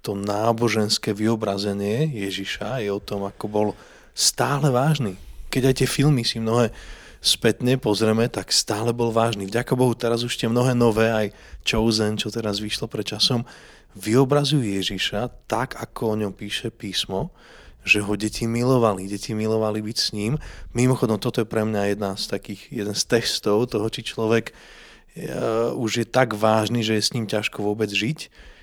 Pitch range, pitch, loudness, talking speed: 105-120 Hz, 110 Hz, -22 LUFS, 170 wpm